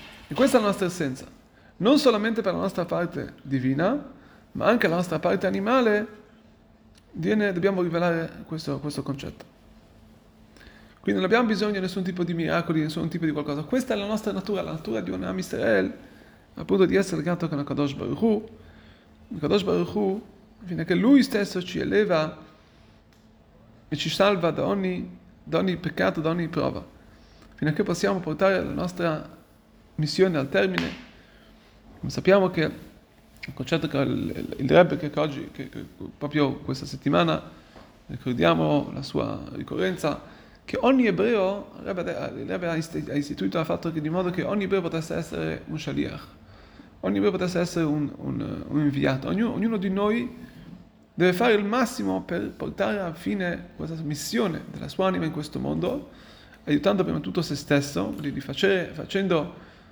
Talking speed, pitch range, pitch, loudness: 165 wpm, 145-200 Hz, 170 Hz, -25 LUFS